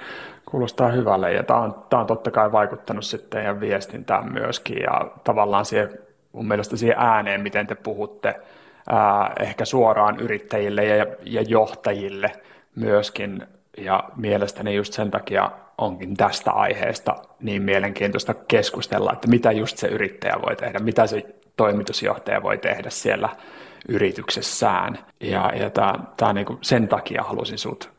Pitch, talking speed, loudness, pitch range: 105 Hz, 140 wpm, -22 LUFS, 100-110 Hz